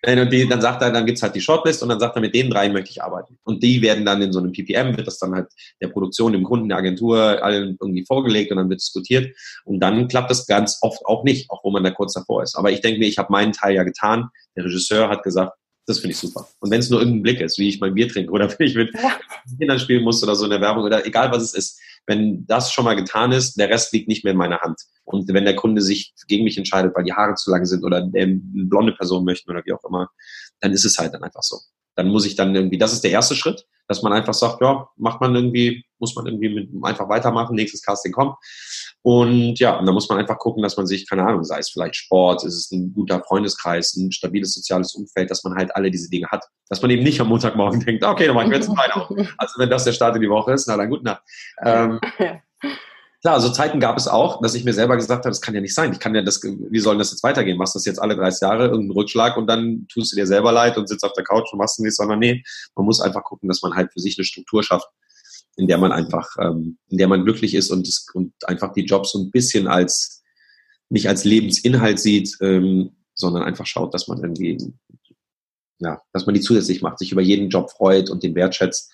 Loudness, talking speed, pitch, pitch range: -19 LUFS, 260 wpm, 105 Hz, 95-115 Hz